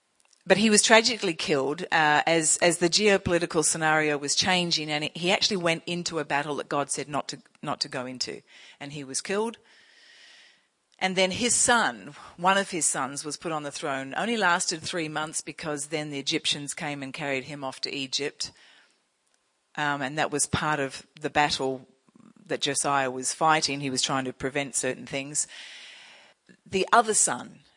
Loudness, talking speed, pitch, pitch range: -25 LUFS, 180 wpm, 150 Hz, 140-175 Hz